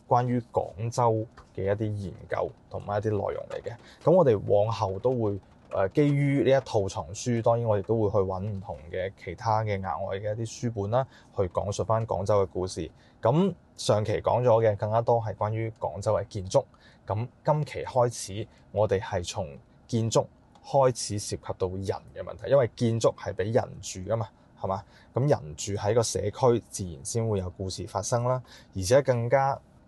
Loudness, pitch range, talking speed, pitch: -28 LUFS, 100-120 Hz, 265 characters per minute, 110 Hz